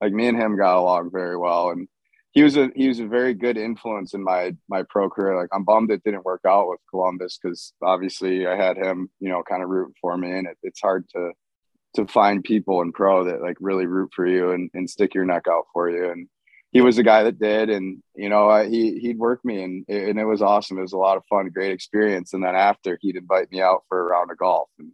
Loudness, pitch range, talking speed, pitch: -21 LUFS, 90-110 Hz, 260 wpm, 95 Hz